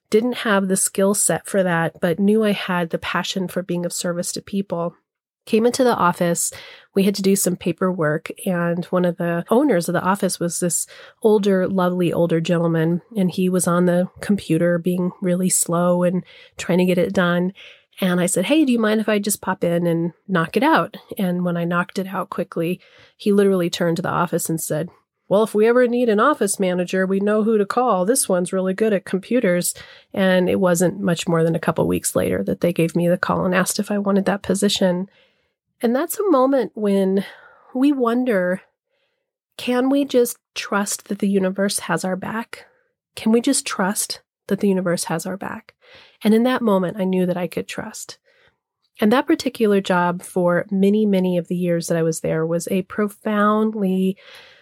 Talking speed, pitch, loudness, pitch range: 205 wpm, 190 Hz, -20 LUFS, 175-220 Hz